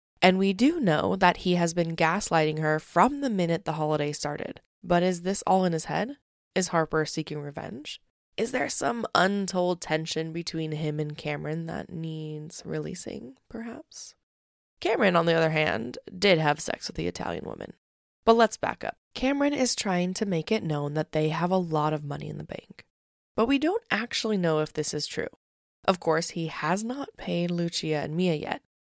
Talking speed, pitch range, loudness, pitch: 190 wpm, 155-195 Hz, -27 LUFS, 170 Hz